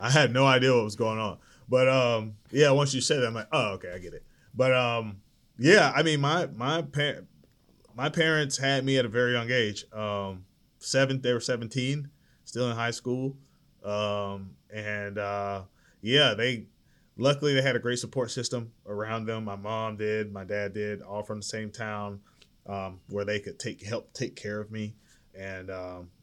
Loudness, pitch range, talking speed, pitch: -27 LUFS, 105-130 Hz, 195 wpm, 115 Hz